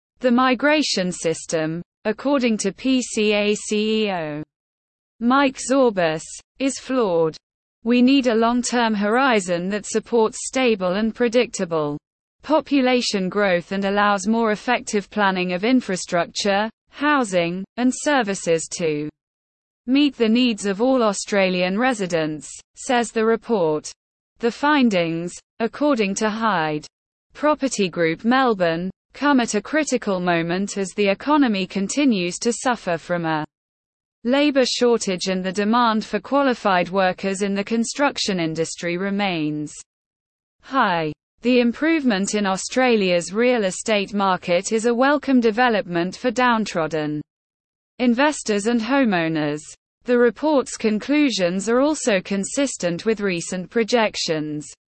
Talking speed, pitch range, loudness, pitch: 115 wpm, 180-250 Hz, -20 LUFS, 215 Hz